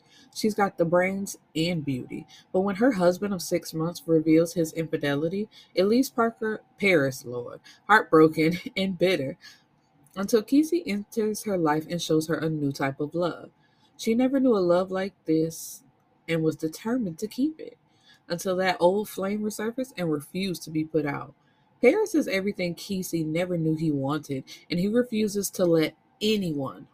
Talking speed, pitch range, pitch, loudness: 165 wpm, 160-210 Hz, 180 Hz, -26 LUFS